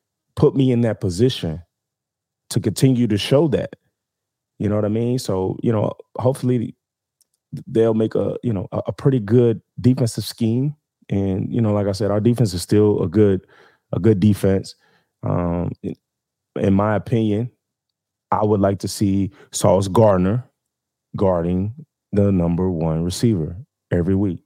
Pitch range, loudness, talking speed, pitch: 95-120 Hz, -20 LUFS, 150 wpm, 105 Hz